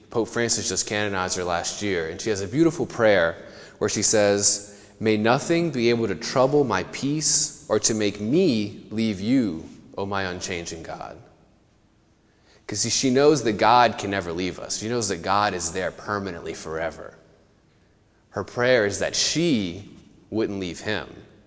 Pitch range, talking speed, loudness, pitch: 100-120 Hz, 165 wpm, -23 LUFS, 105 Hz